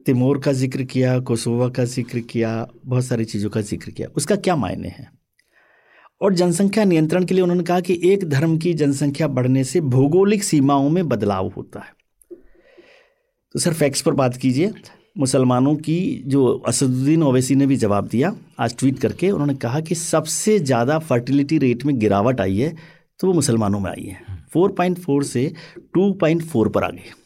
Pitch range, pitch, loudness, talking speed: 125-175 Hz, 140 Hz, -19 LUFS, 175 wpm